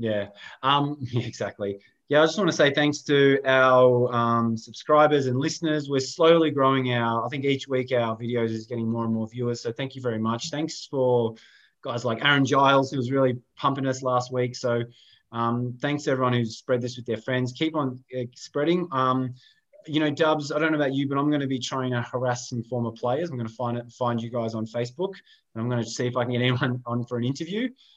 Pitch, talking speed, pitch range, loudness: 125 Hz, 235 wpm, 120-145 Hz, -25 LUFS